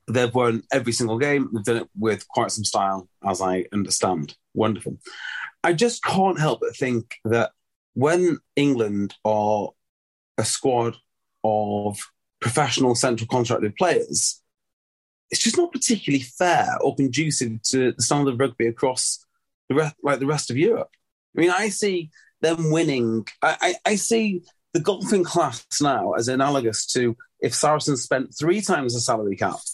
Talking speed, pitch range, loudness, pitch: 155 wpm, 115-170 Hz, -22 LUFS, 135 Hz